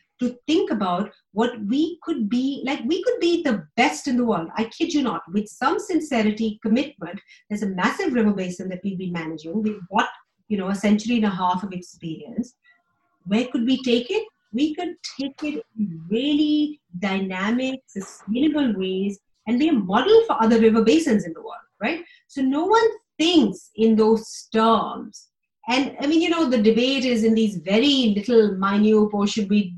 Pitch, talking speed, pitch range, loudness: 225 Hz, 185 wpm, 205-290 Hz, -22 LUFS